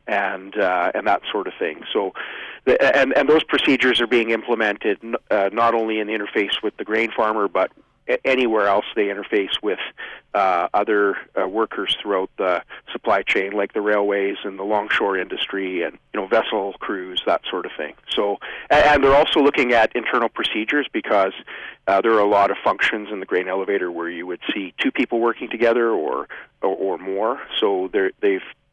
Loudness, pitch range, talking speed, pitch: -20 LUFS, 100-140 Hz, 195 wpm, 115 Hz